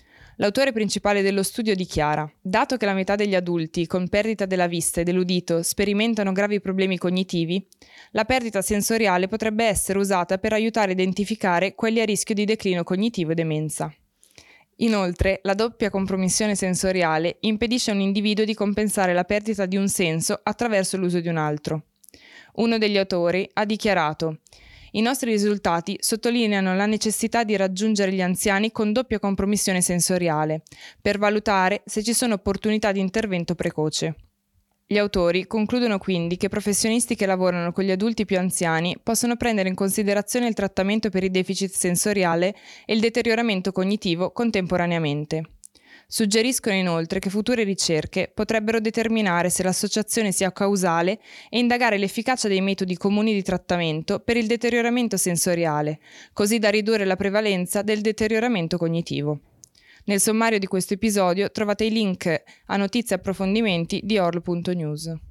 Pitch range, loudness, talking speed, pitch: 180-220 Hz, -22 LUFS, 145 wpm, 195 Hz